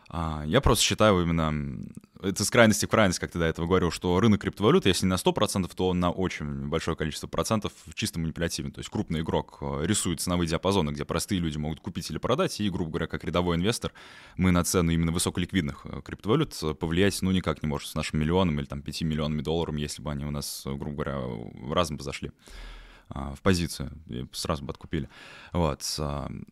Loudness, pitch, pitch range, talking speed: -27 LUFS, 85 Hz, 75-95 Hz, 195 wpm